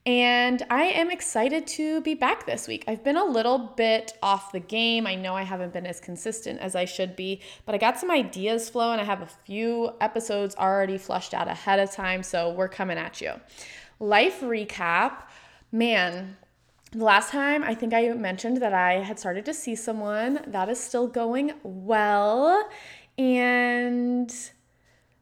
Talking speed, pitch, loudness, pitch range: 175 wpm, 225 Hz, -25 LUFS, 195-245 Hz